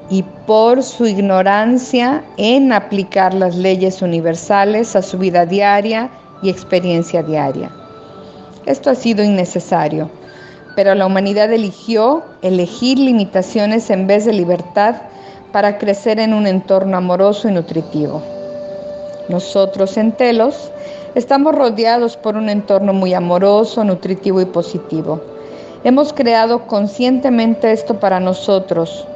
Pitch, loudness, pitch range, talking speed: 200 Hz, -14 LUFS, 185-230 Hz, 115 wpm